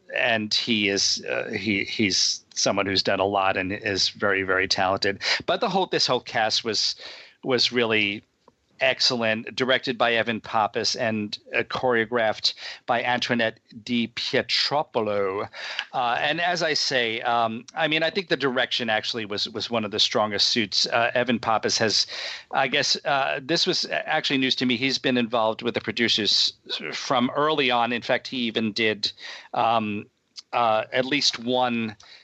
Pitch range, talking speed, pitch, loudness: 110-130 Hz, 165 wpm, 115 Hz, -23 LUFS